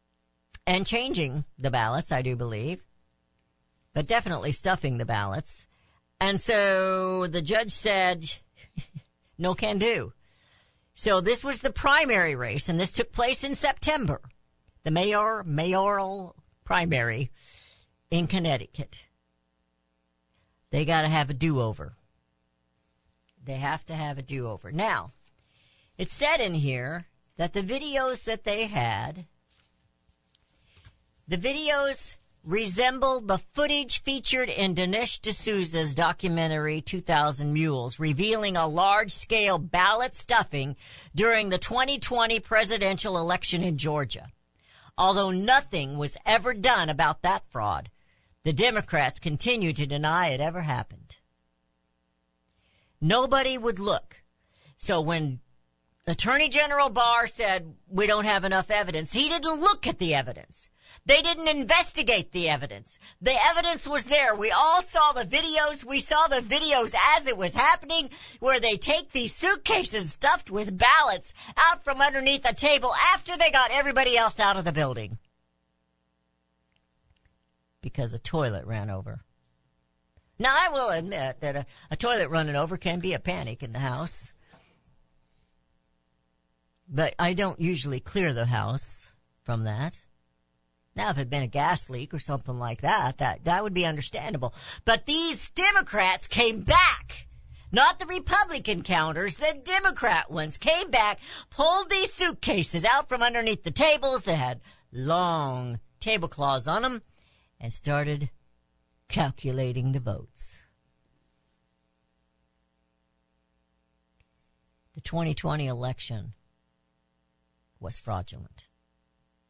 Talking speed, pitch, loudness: 130 wpm, 165 Hz, -25 LUFS